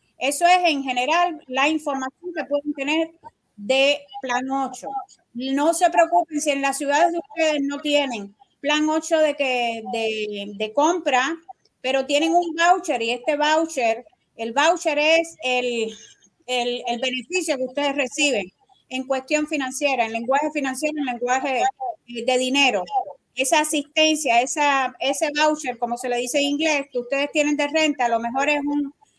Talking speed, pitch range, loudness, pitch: 160 wpm, 255-315 Hz, -21 LUFS, 285 Hz